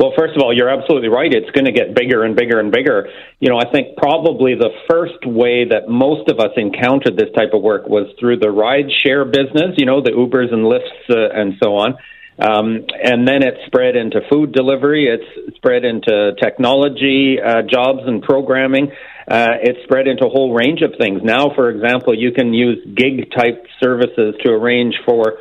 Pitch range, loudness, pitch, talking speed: 120-145 Hz, -14 LUFS, 130 Hz, 205 wpm